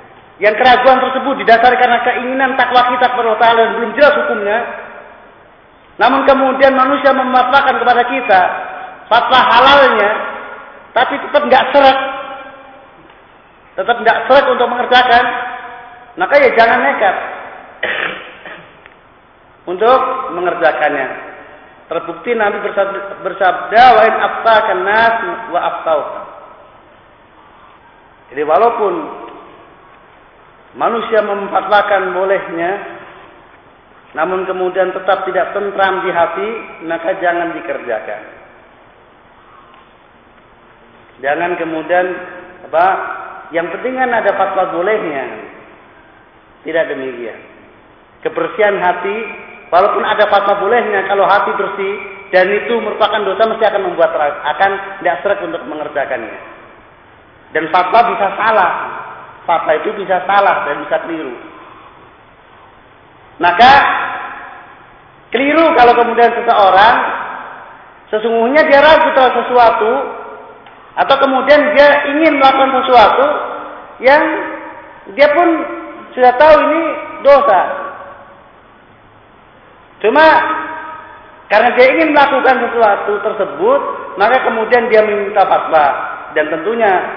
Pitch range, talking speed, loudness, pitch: 190-270 Hz, 95 wpm, -12 LUFS, 230 Hz